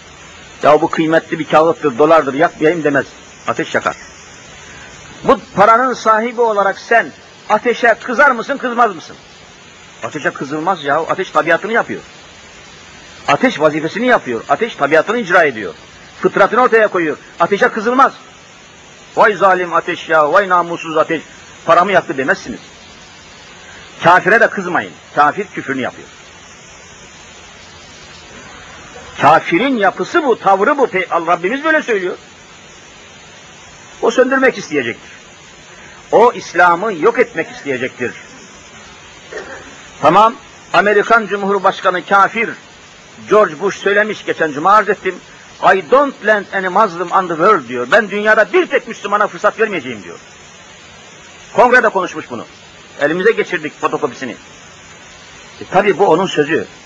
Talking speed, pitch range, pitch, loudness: 115 wpm, 160-225 Hz, 195 Hz, -13 LUFS